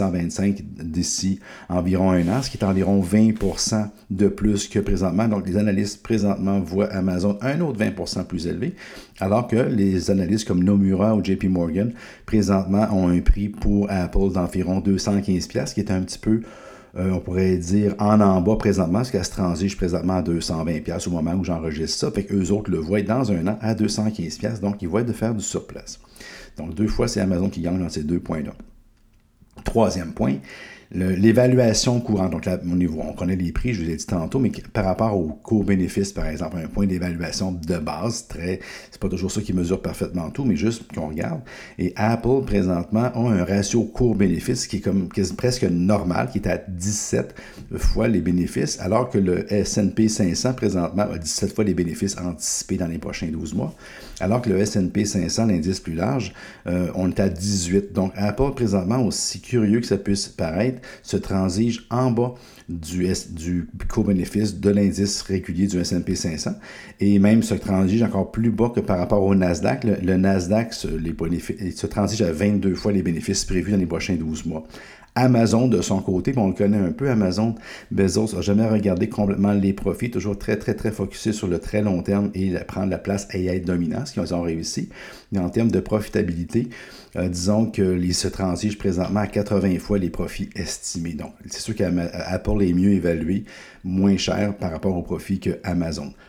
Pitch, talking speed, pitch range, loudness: 100 Hz, 195 wpm, 90-105 Hz, -22 LUFS